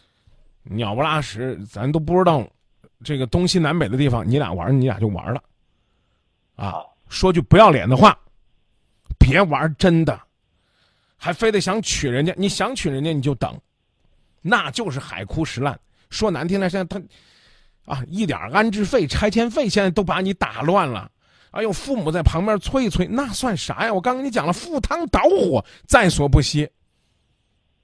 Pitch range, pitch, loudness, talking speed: 140-205 Hz, 170 Hz, -20 LUFS, 240 characters per minute